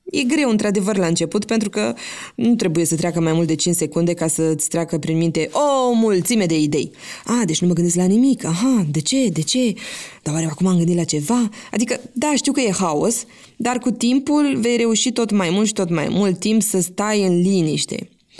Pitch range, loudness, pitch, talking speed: 170-240 Hz, -18 LUFS, 210 Hz, 220 wpm